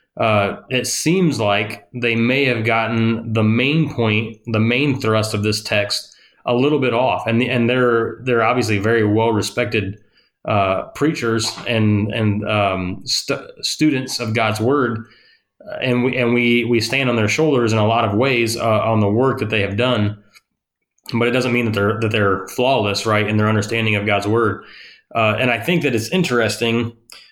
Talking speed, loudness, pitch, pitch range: 185 wpm, -18 LUFS, 115 Hz, 105-125 Hz